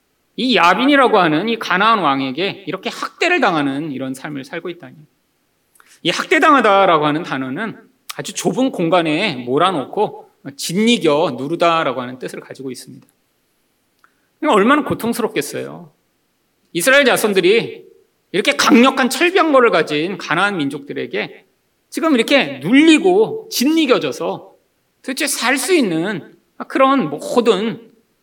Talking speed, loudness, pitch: 295 characters per minute, -15 LUFS, 230 Hz